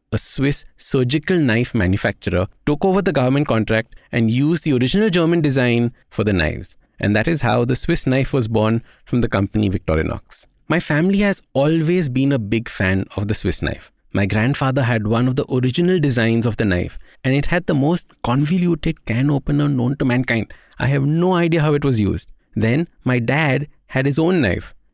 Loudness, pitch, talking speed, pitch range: -19 LUFS, 130 Hz, 195 wpm, 110-155 Hz